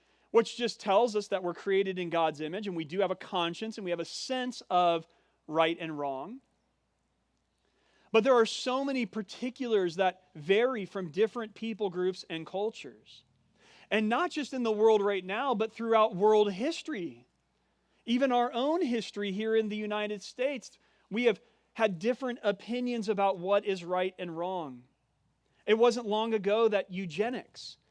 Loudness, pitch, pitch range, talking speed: -30 LUFS, 210 Hz, 185-235 Hz, 165 wpm